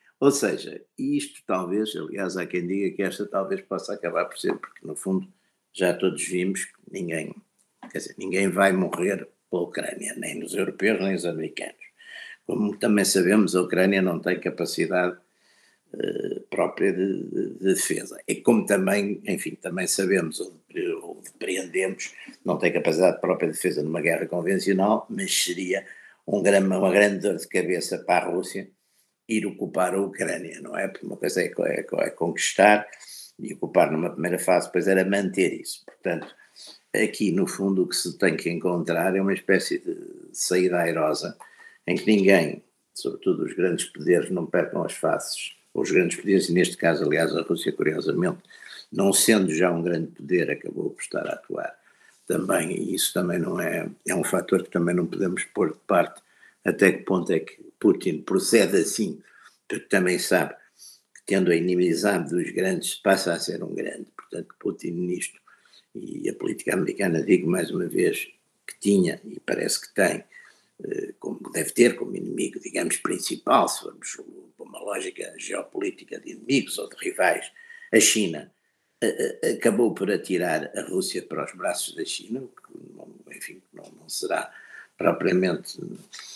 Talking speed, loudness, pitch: 170 wpm, -25 LUFS, 330 Hz